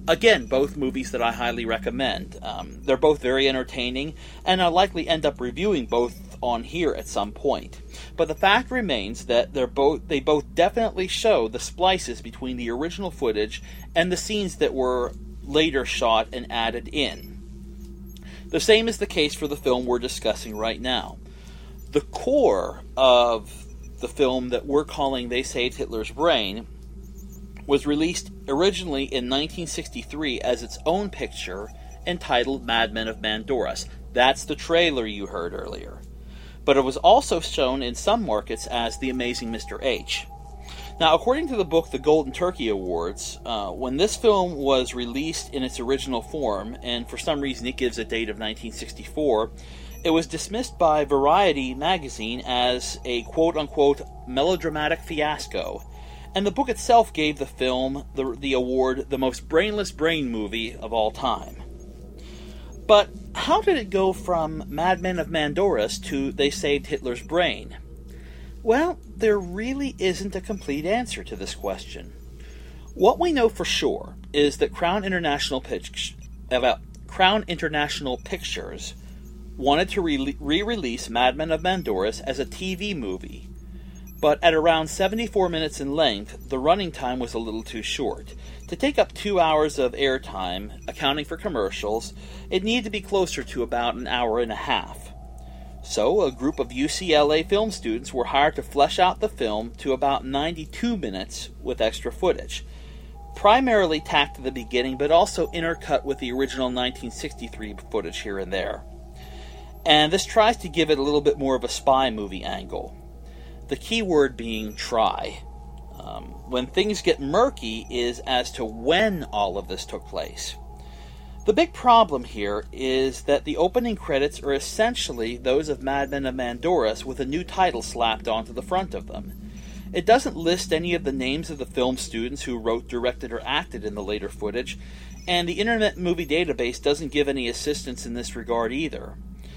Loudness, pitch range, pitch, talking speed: -24 LUFS, 115-175 Hz, 135 Hz, 165 wpm